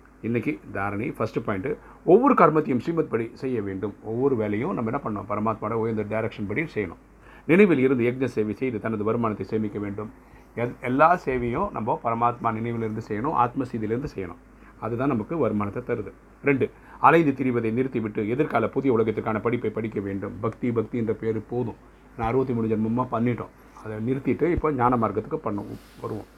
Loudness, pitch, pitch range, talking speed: -25 LUFS, 115 Hz, 110-125 Hz, 155 wpm